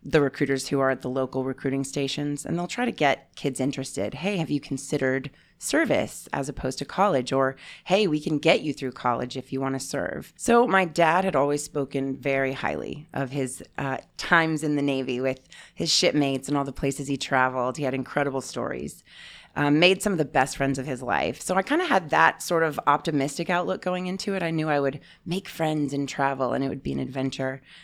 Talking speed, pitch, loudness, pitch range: 220 wpm, 140 Hz, -25 LUFS, 135-160 Hz